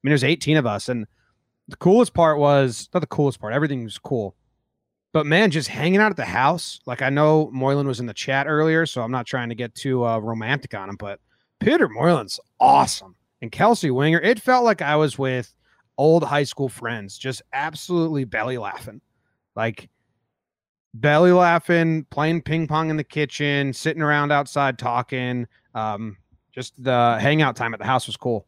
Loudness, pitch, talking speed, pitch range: -21 LUFS, 135 Hz, 190 wpm, 120-155 Hz